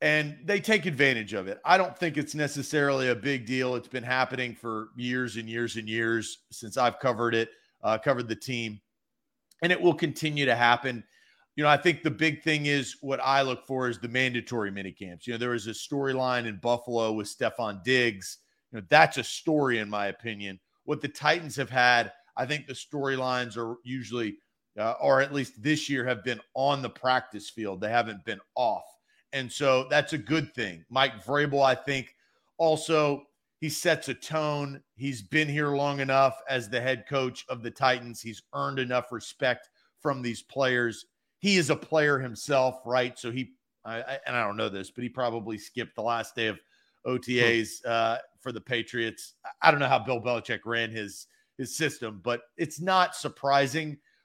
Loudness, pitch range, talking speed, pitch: -28 LUFS, 115-145 Hz, 195 wpm, 130 Hz